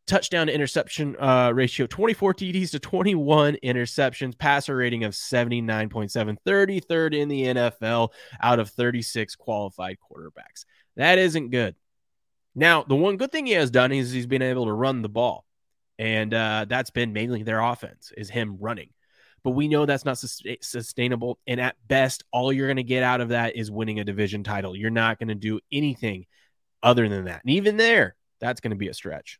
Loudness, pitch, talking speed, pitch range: -24 LUFS, 125 Hz, 190 wpm, 110-140 Hz